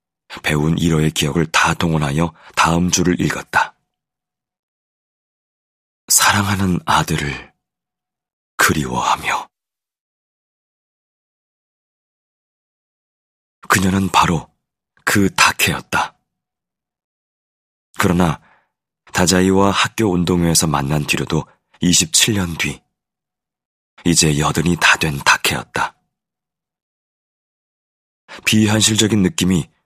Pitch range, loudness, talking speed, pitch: 80-95 Hz, -16 LUFS, 165 characters per minute, 85 Hz